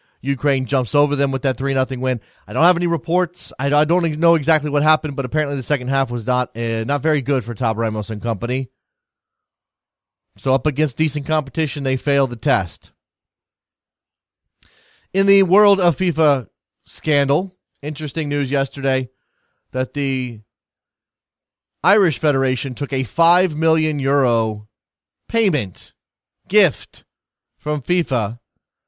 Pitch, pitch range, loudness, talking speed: 140 Hz, 130-155 Hz, -19 LUFS, 145 wpm